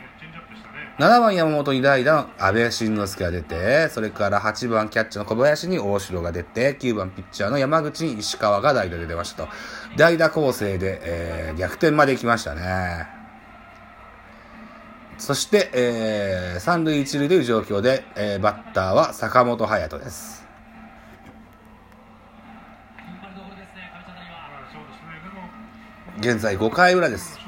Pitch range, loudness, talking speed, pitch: 100-150 Hz, -21 LUFS, 225 characters per minute, 110 Hz